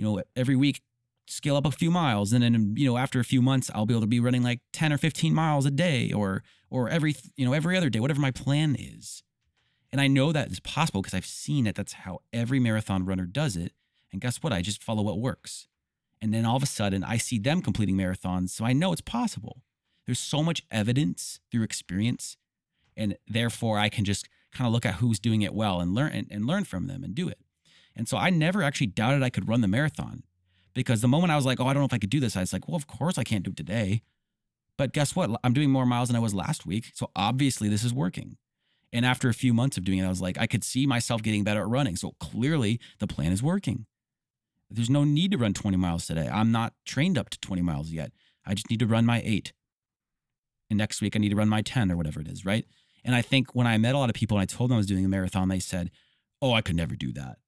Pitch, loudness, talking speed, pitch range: 120 Hz, -27 LUFS, 265 wpm, 105-135 Hz